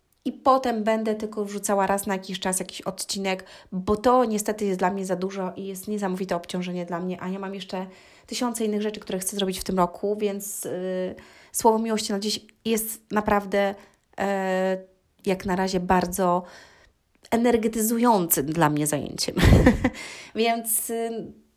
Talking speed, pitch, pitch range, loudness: 160 wpm, 195 Hz, 185-220 Hz, -25 LUFS